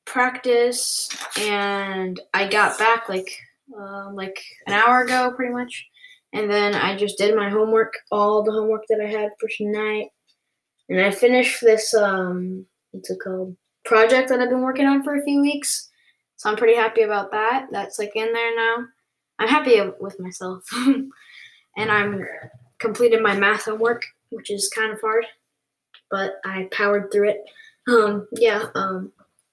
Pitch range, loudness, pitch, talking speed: 200-235 Hz, -20 LUFS, 215 Hz, 165 wpm